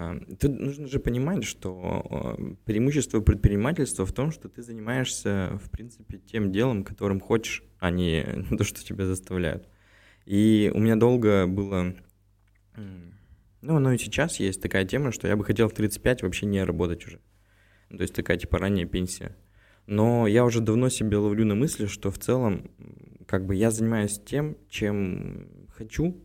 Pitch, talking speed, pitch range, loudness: 105 Hz, 160 wpm, 95-115 Hz, -26 LUFS